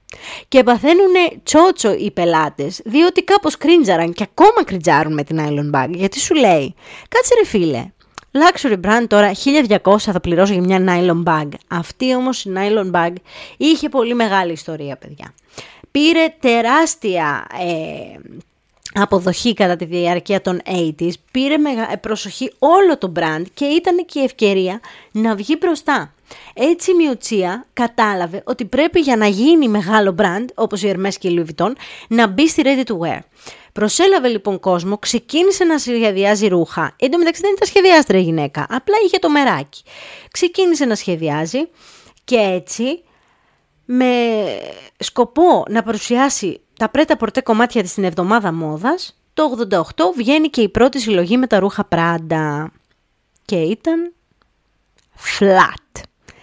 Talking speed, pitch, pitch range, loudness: 145 wpm, 225 Hz, 185-295 Hz, -15 LUFS